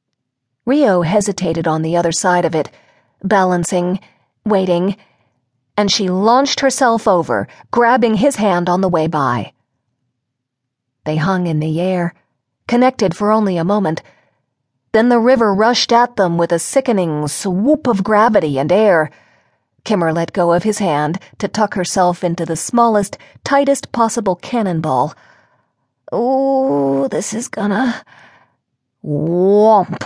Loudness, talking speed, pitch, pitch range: -15 LUFS, 130 wpm, 190 Hz, 165-225 Hz